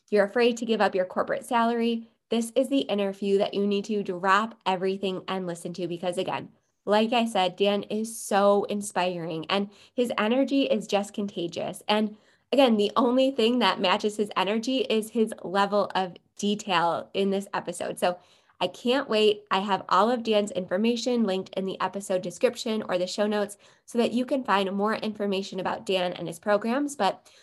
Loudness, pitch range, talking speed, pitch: -26 LUFS, 190-225 Hz, 185 wpm, 205 Hz